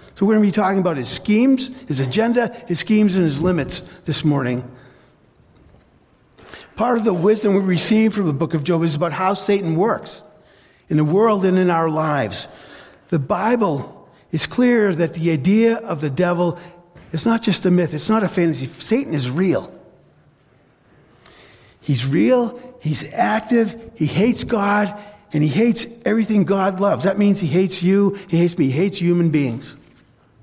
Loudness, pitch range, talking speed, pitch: -18 LUFS, 155-210 Hz, 175 wpm, 180 Hz